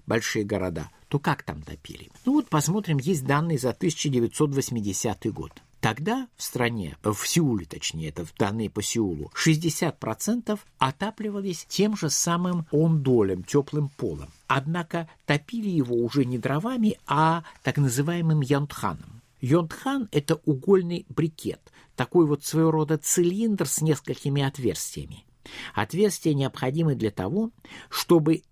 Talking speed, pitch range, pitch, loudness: 125 wpm, 130-175 Hz, 155 Hz, -26 LUFS